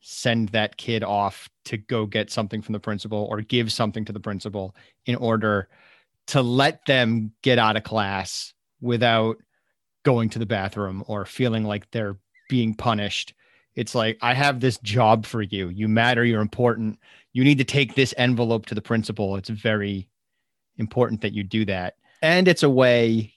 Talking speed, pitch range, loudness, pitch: 175 wpm, 105-120 Hz, -23 LUFS, 110 Hz